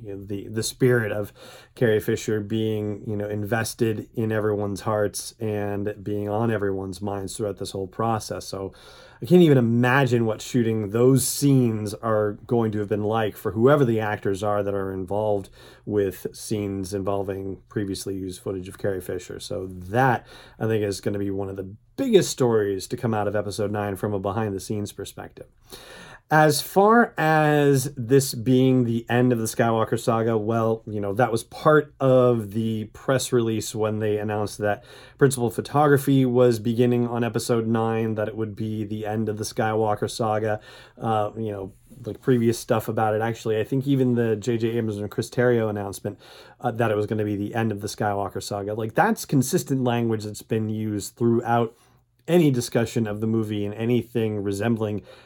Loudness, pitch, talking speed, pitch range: -24 LUFS, 110 Hz, 185 wpm, 105-120 Hz